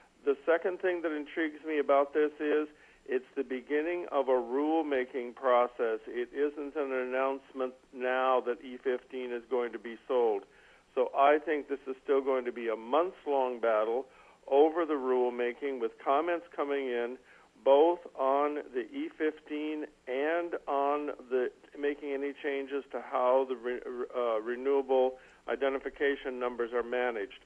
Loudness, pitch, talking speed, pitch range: -32 LUFS, 140 Hz, 150 wpm, 130-155 Hz